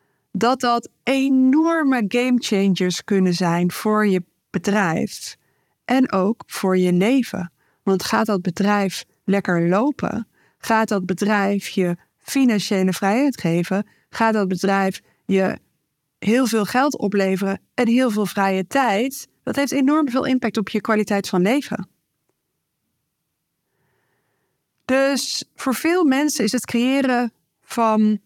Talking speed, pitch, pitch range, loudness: 125 wpm, 210 Hz, 190-250 Hz, -20 LUFS